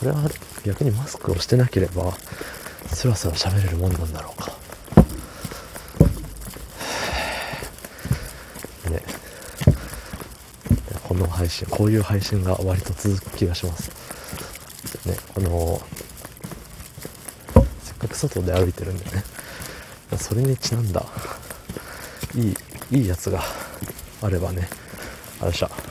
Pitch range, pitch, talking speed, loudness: 90-105 Hz, 95 Hz, 210 characters per minute, -24 LUFS